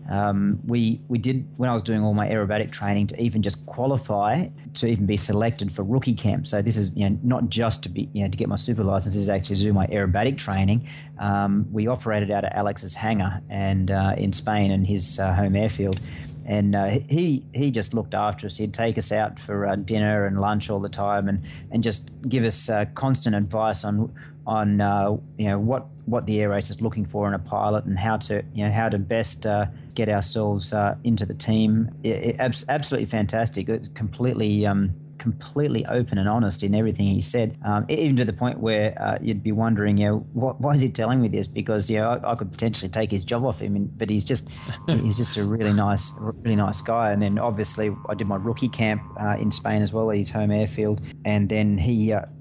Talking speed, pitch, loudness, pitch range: 230 wpm, 105 Hz, -24 LUFS, 100-115 Hz